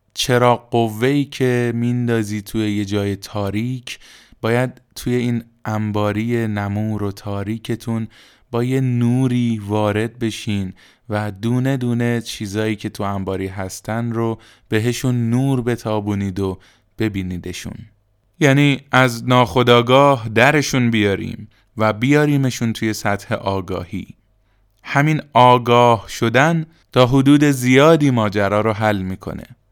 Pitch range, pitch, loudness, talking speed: 105-125 Hz, 115 Hz, -18 LUFS, 110 wpm